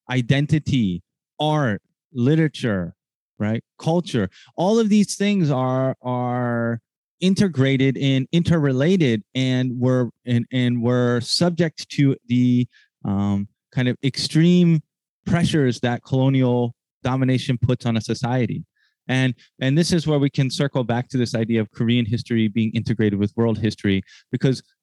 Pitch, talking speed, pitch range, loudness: 130 Hz, 130 wpm, 120-145 Hz, -21 LUFS